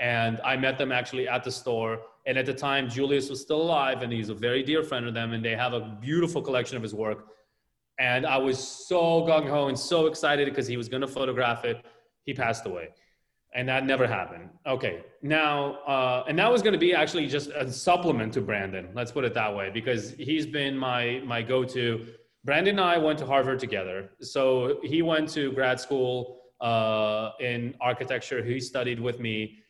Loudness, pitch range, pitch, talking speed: -27 LUFS, 120-140 Hz, 130 Hz, 205 wpm